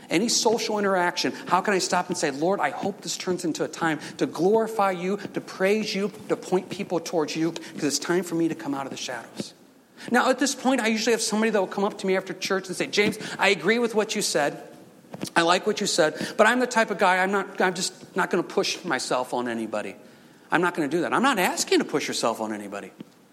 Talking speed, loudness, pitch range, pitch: 255 wpm, -24 LUFS, 170-210 Hz, 190 Hz